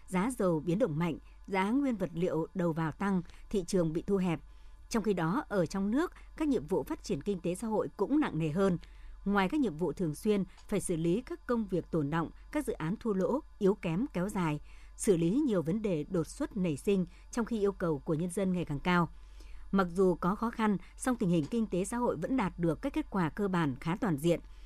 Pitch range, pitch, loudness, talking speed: 170-215 Hz, 190 Hz, -33 LUFS, 245 wpm